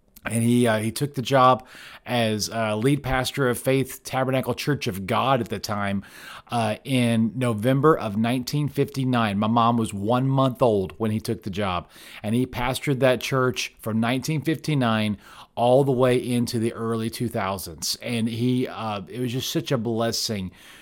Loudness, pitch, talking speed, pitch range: -24 LUFS, 120 Hz, 170 wpm, 110-130 Hz